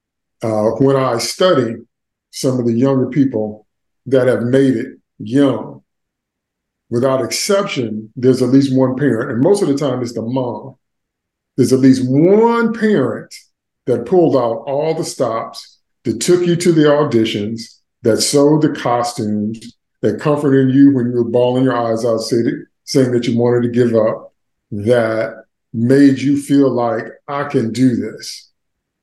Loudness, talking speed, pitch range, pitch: -15 LUFS, 160 wpm, 115-140 Hz, 130 Hz